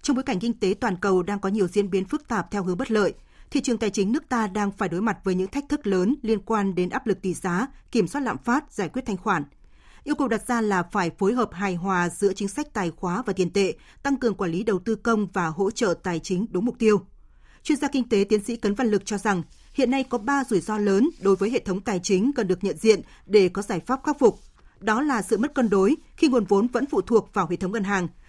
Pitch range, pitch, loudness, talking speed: 195-245 Hz, 205 Hz, -24 LUFS, 280 wpm